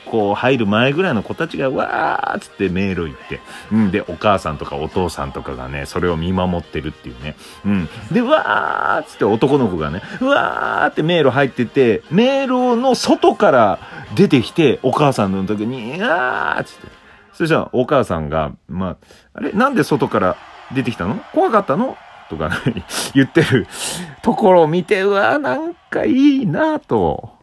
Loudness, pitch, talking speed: -17 LUFS, 130 Hz, 340 characters per minute